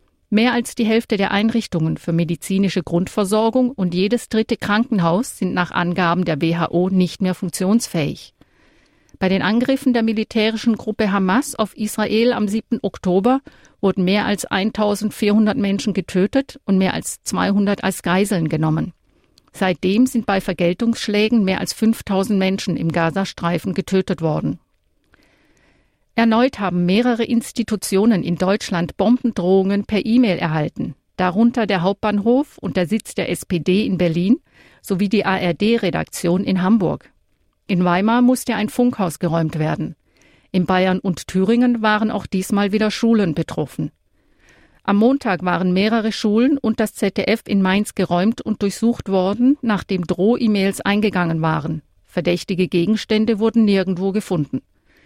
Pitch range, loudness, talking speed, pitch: 185-225 Hz, -19 LUFS, 135 wpm, 200 Hz